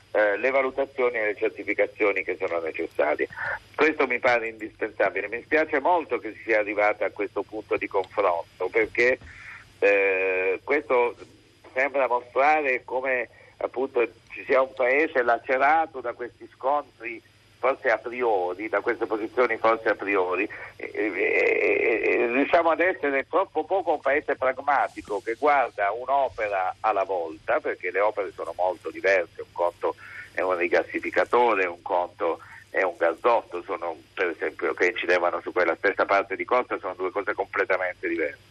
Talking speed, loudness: 150 wpm, -25 LUFS